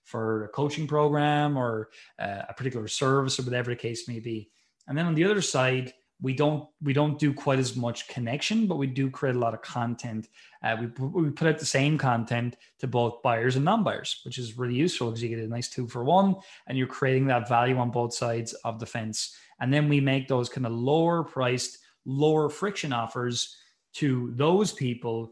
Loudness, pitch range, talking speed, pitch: -27 LUFS, 120-145 Hz, 210 wpm, 130 Hz